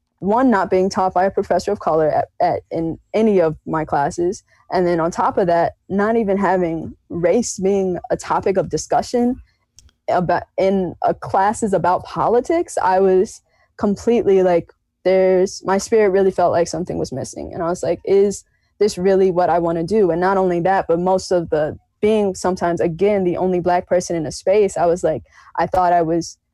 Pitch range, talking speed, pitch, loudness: 170-195 Hz, 195 wpm, 185 Hz, -18 LUFS